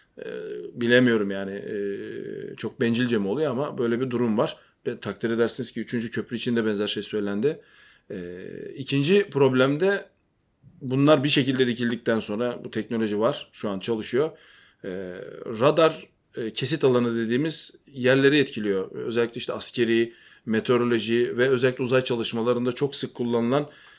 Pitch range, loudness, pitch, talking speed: 115-130 Hz, -24 LUFS, 120 Hz, 135 wpm